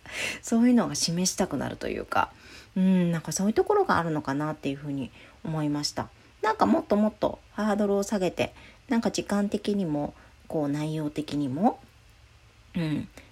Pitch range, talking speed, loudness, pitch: 150-205 Hz, 360 characters per minute, -27 LUFS, 175 Hz